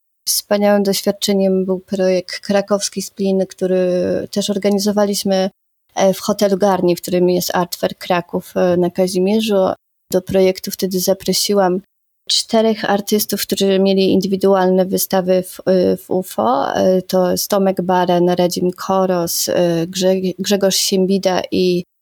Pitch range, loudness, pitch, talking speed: 185-200 Hz, -16 LUFS, 190 Hz, 110 wpm